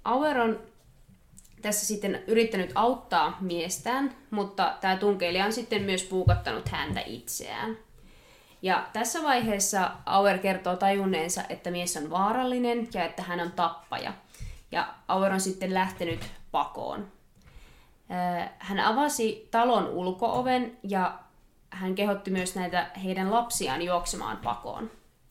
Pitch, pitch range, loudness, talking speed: 195 Hz, 180-225 Hz, -28 LUFS, 120 wpm